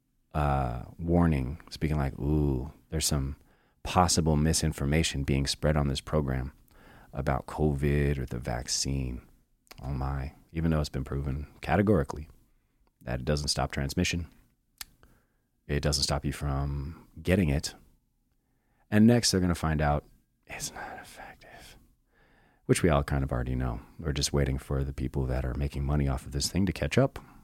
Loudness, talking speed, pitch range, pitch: -29 LUFS, 160 wpm, 70-80 Hz, 70 Hz